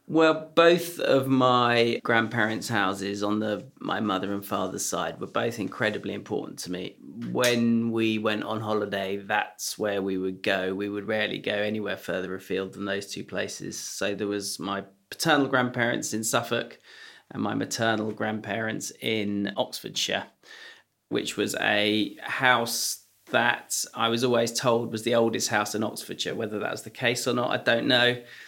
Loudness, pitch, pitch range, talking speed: -26 LUFS, 110 Hz, 100-120 Hz, 165 wpm